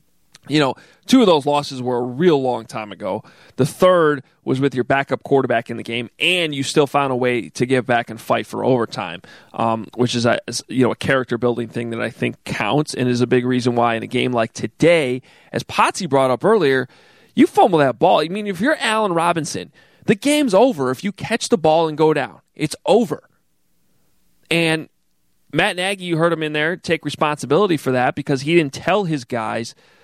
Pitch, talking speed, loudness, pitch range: 140 Hz, 210 wpm, -18 LUFS, 125-165 Hz